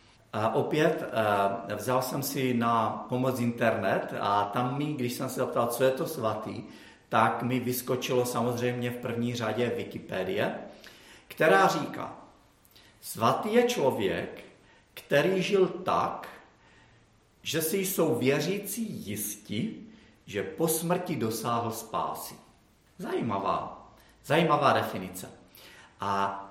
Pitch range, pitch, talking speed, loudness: 110-145 Hz, 125 Hz, 110 wpm, -29 LUFS